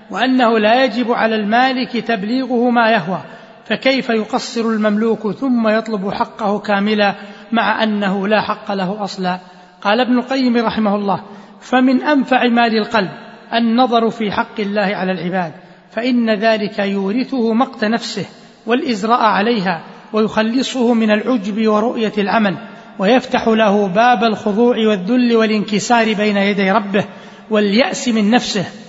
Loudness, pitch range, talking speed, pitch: -16 LUFS, 205-235 Hz, 125 wpm, 220 Hz